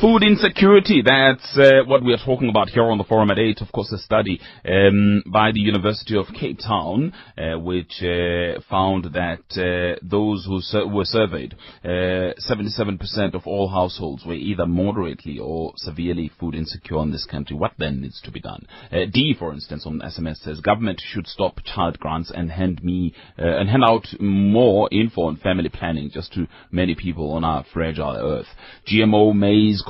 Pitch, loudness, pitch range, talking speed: 95 Hz, -20 LUFS, 85-105 Hz, 185 wpm